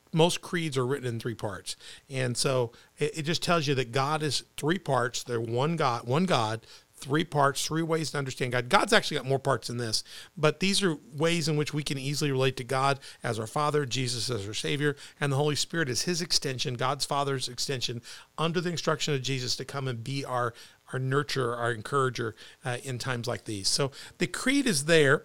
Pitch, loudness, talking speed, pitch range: 140 Hz, -28 LUFS, 215 wpm, 125-155 Hz